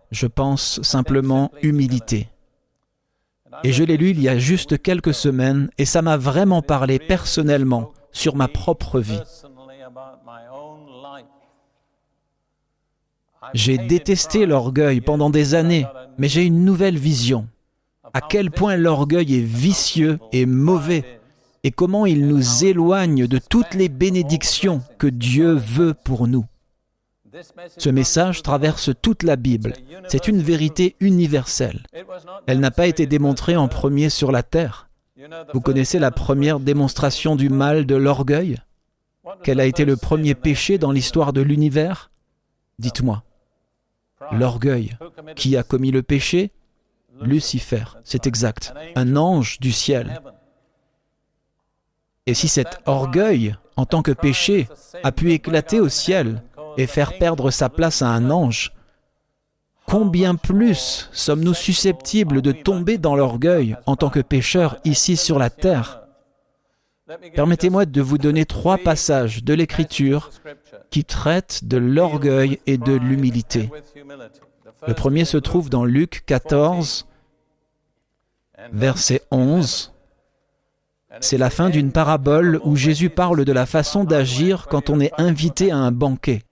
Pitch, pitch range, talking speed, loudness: 145 Hz, 130-165 Hz, 130 wpm, -18 LUFS